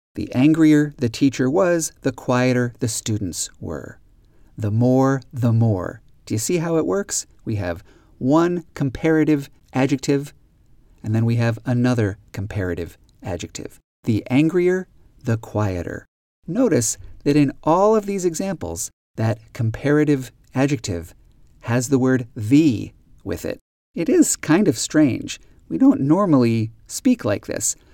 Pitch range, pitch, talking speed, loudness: 110-150 Hz, 125 Hz, 135 wpm, -20 LUFS